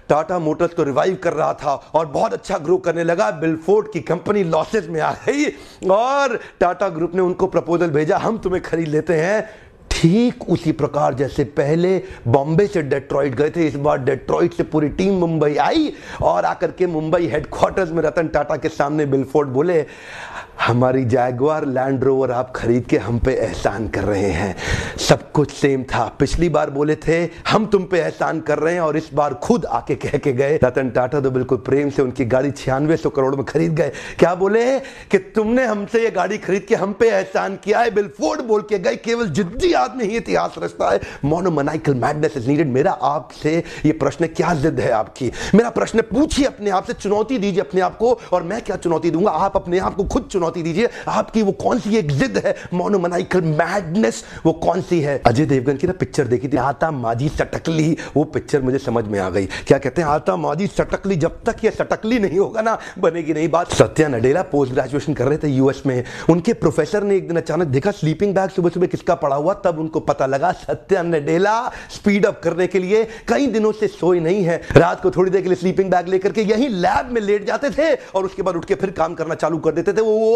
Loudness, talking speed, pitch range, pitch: -19 LUFS, 150 wpm, 145-195 Hz, 170 Hz